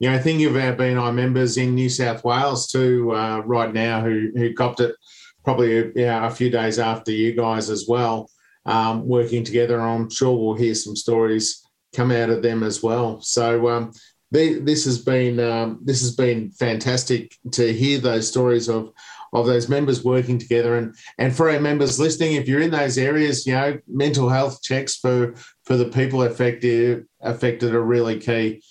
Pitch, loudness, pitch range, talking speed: 120 Hz, -20 LUFS, 115-130 Hz, 180 wpm